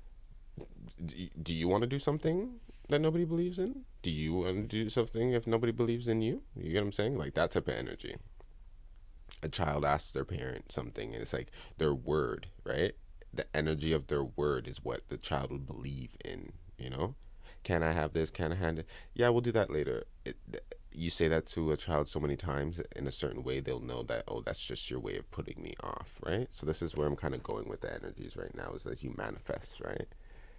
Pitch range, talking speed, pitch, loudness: 75-120 Hz, 230 wpm, 85 Hz, -35 LUFS